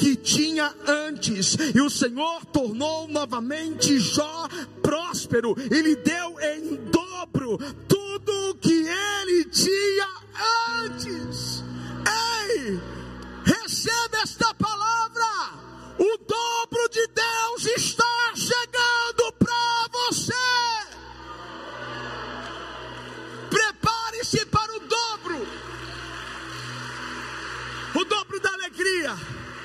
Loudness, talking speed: -24 LUFS, 85 wpm